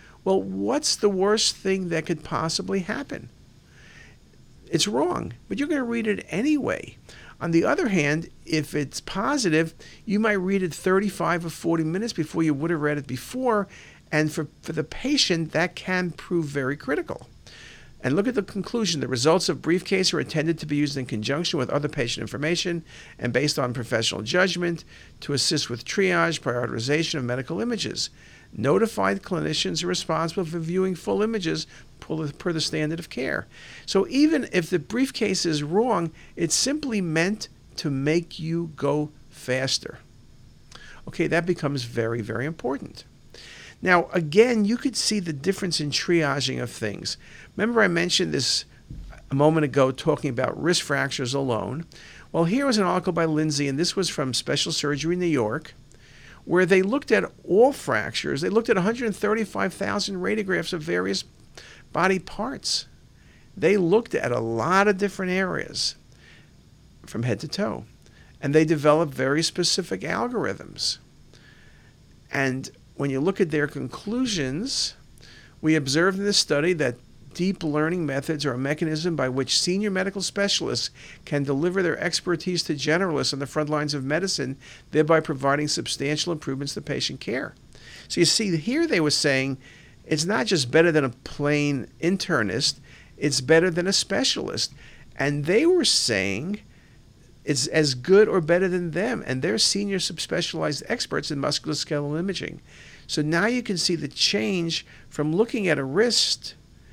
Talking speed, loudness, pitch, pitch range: 160 wpm, -24 LUFS, 160 Hz, 140-190 Hz